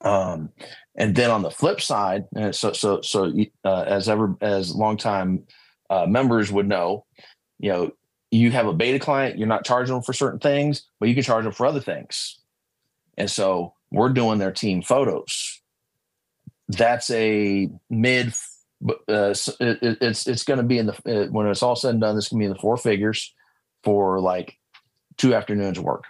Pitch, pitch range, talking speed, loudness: 110 Hz, 100-125 Hz, 185 wpm, -22 LUFS